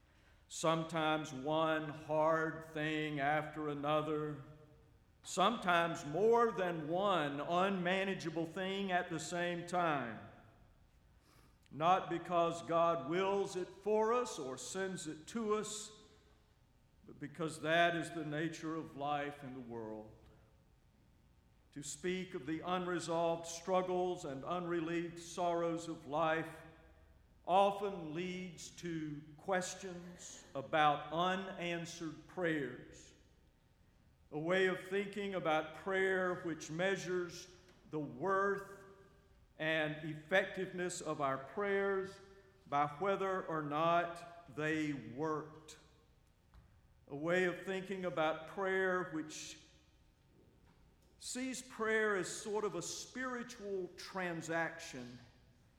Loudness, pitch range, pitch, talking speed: -38 LUFS, 155-185 Hz, 170 Hz, 100 wpm